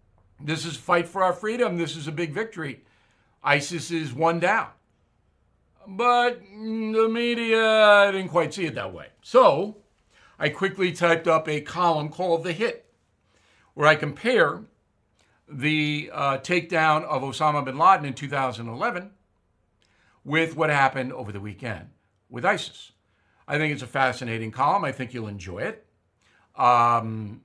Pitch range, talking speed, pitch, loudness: 125-180 Hz, 145 wpm, 155 Hz, -23 LUFS